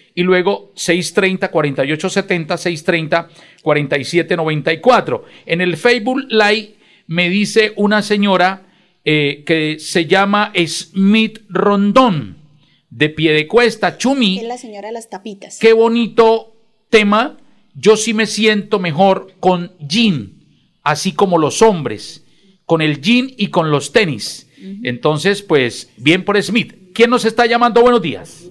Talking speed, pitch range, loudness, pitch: 135 wpm, 165-220 Hz, -14 LUFS, 190 Hz